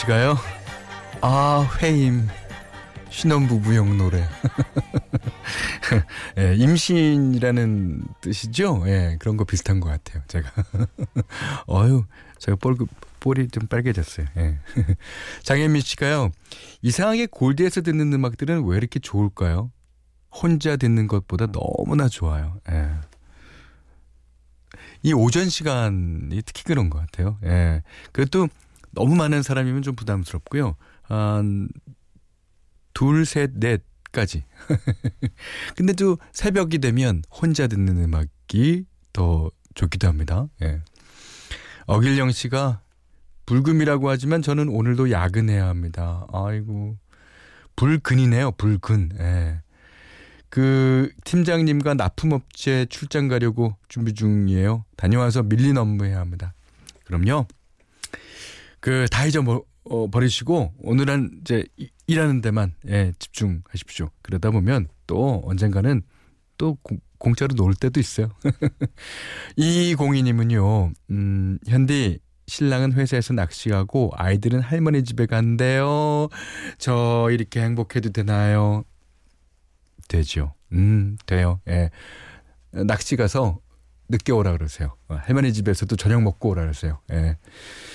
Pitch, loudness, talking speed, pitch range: 110 Hz, -22 LUFS, 235 characters per minute, 90-130 Hz